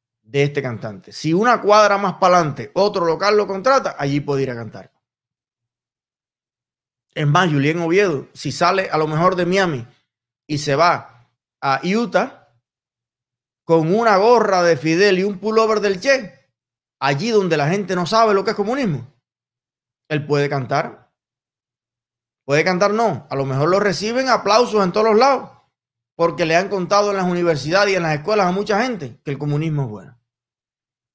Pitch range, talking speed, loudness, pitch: 130-195 Hz, 170 wpm, -18 LUFS, 155 Hz